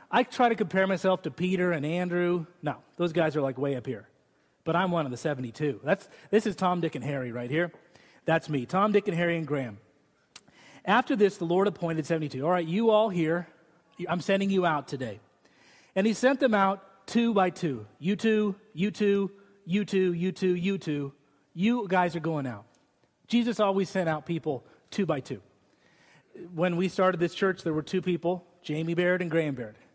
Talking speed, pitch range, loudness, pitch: 200 wpm, 155-195 Hz, -28 LUFS, 175 Hz